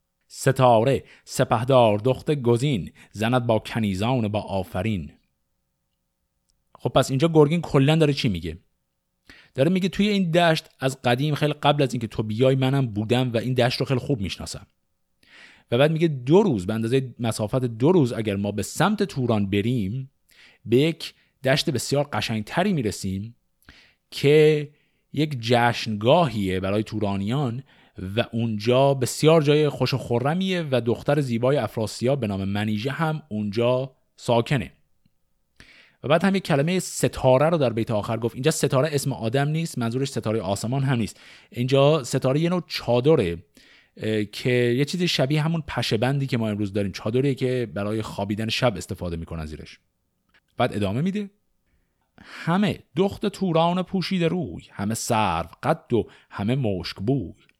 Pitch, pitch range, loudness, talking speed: 125 Hz, 110-150 Hz, -23 LUFS, 150 wpm